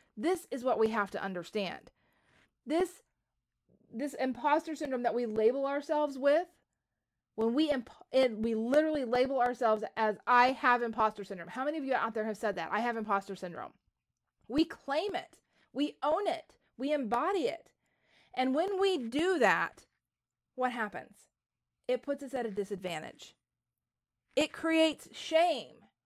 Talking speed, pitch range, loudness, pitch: 155 wpm, 220-300 Hz, -32 LUFS, 255 Hz